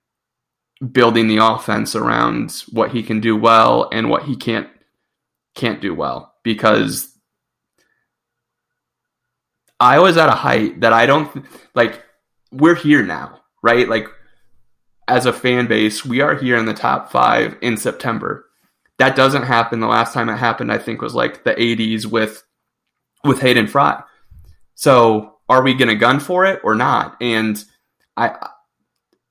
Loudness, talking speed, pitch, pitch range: -15 LUFS, 155 wpm, 115 Hz, 110-130 Hz